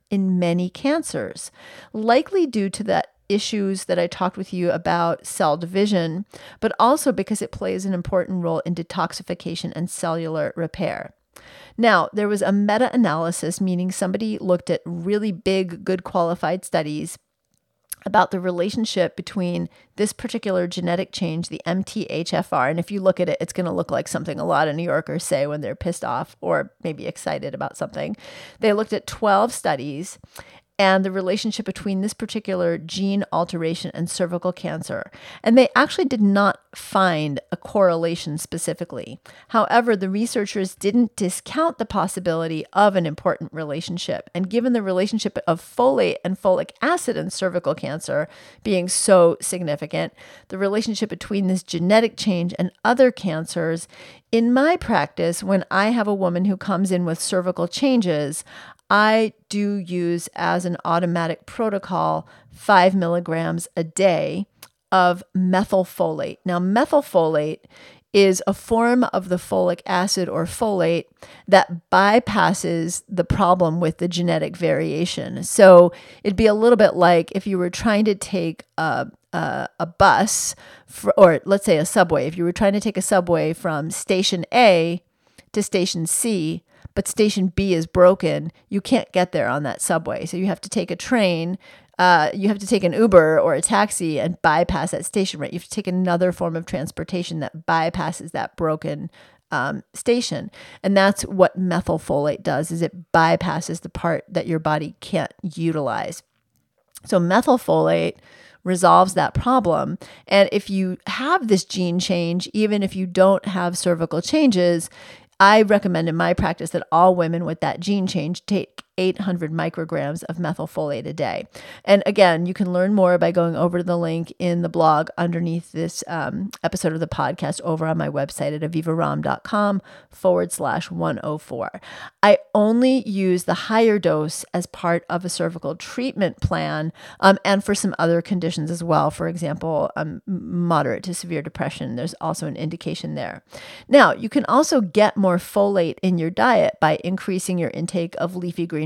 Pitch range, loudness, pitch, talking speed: 170-200 Hz, -20 LUFS, 185 Hz, 165 wpm